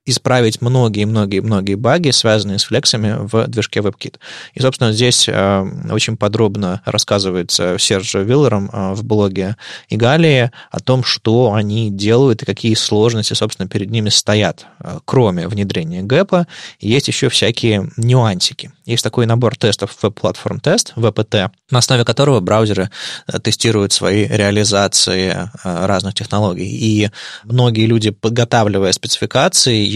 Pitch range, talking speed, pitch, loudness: 100-120 Hz, 130 wpm, 110 Hz, -14 LUFS